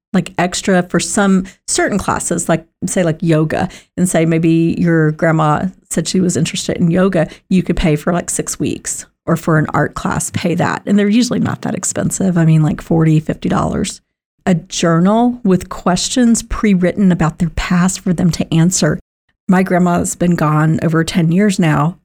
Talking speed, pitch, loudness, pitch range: 180 wpm, 175 Hz, -15 LUFS, 165-190 Hz